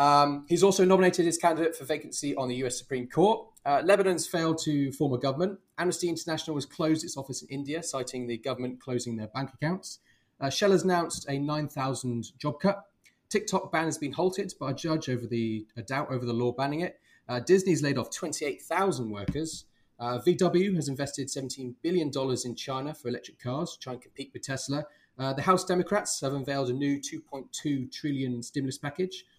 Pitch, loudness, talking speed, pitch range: 145 Hz, -29 LUFS, 190 wpm, 130-170 Hz